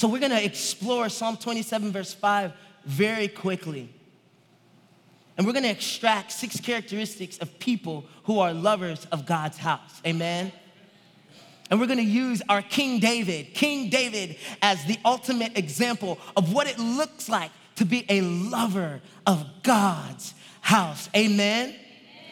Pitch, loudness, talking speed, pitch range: 205 Hz, -25 LUFS, 135 wpm, 180-230 Hz